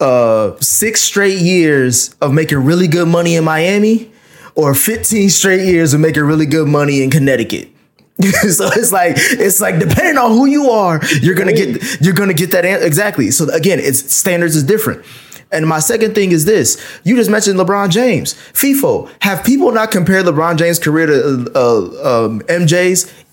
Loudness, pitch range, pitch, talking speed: -11 LUFS, 155-205 Hz, 180 Hz, 185 wpm